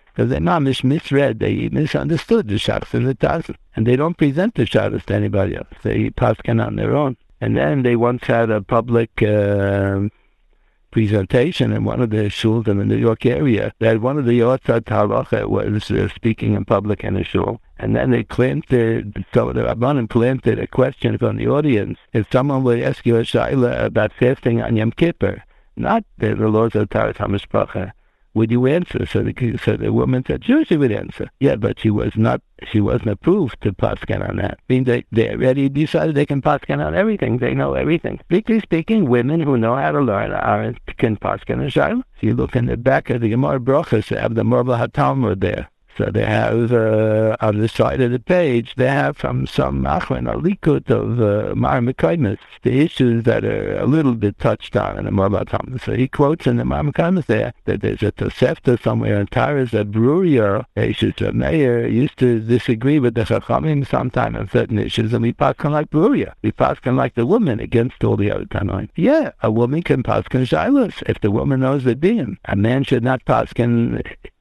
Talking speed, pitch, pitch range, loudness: 205 wpm, 120 Hz, 110-135 Hz, -18 LUFS